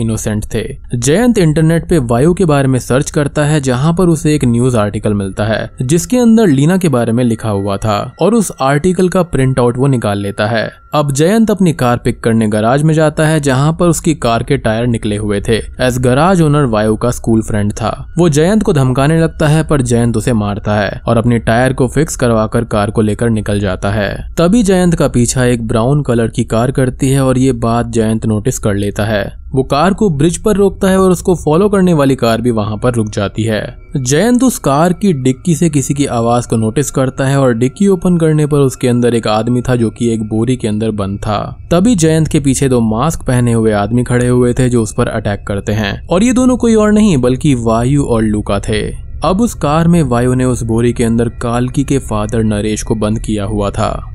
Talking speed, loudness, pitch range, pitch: 230 wpm, -12 LUFS, 110-155 Hz, 125 Hz